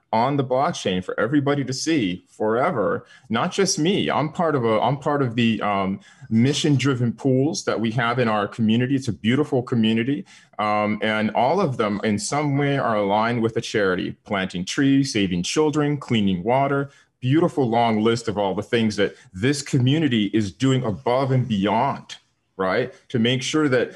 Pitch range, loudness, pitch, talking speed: 110-140 Hz, -22 LUFS, 125 Hz, 180 wpm